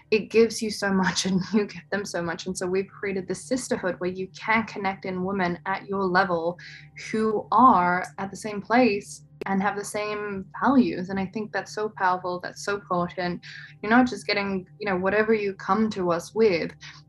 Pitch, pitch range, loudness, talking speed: 195 Hz, 180-210 Hz, -25 LUFS, 205 wpm